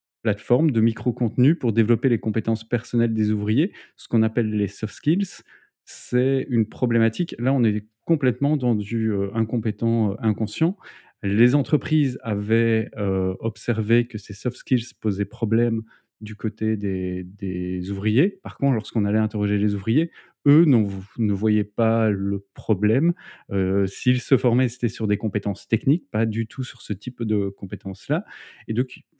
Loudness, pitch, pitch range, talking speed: -23 LUFS, 115 Hz, 105-125 Hz, 160 wpm